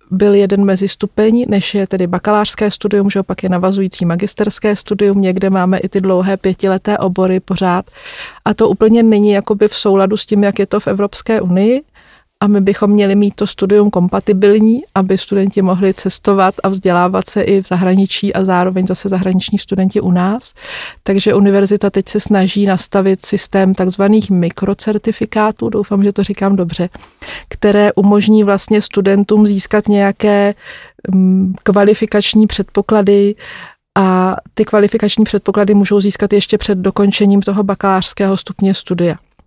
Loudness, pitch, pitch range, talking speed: -12 LUFS, 200 Hz, 190-210 Hz, 150 wpm